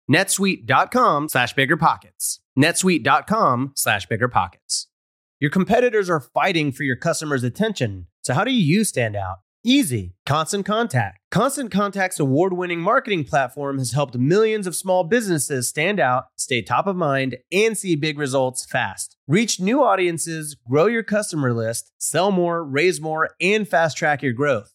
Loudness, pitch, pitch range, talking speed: -20 LUFS, 160 Hz, 135-195 Hz, 145 wpm